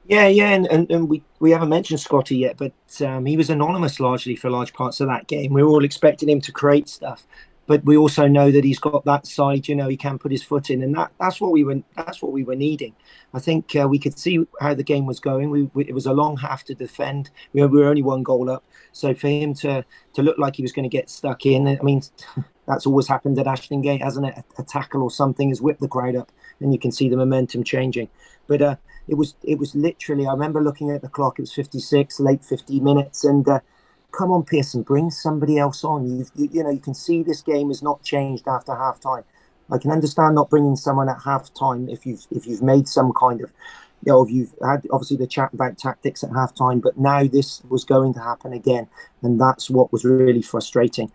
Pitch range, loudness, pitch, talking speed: 130-150 Hz, -20 LUFS, 140 Hz, 250 wpm